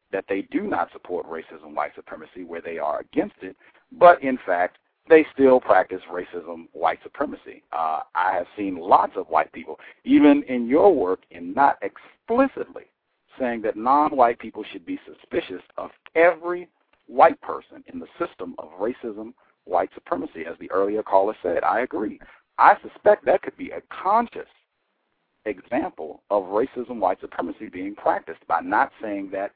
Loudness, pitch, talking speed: -22 LUFS, 175 Hz, 165 wpm